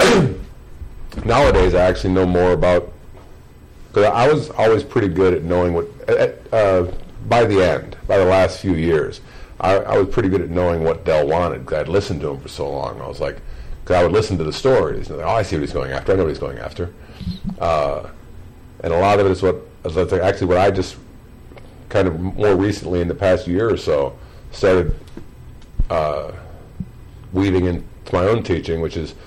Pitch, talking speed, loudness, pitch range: 90 Hz, 205 wpm, -18 LUFS, 85-95 Hz